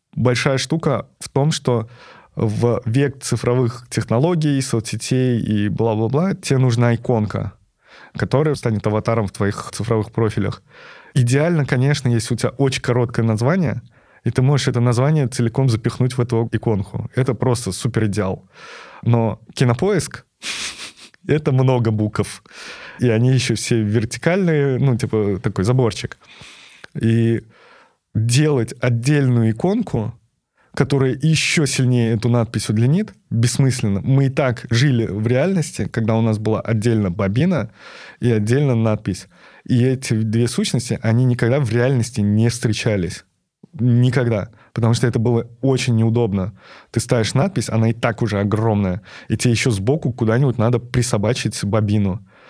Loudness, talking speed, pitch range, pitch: -19 LUFS, 135 wpm, 110-130 Hz, 120 Hz